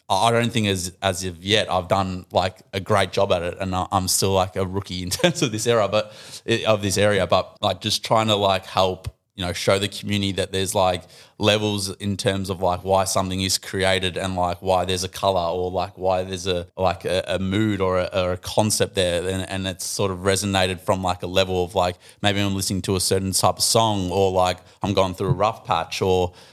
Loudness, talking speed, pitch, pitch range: -22 LUFS, 235 wpm, 95 Hz, 90-105 Hz